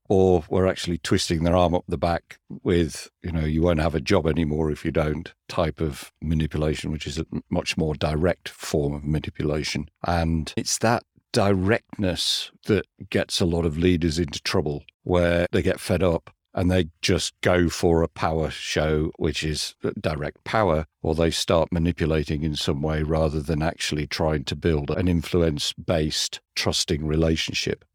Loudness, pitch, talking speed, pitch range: -24 LUFS, 80 Hz, 170 wpm, 75-90 Hz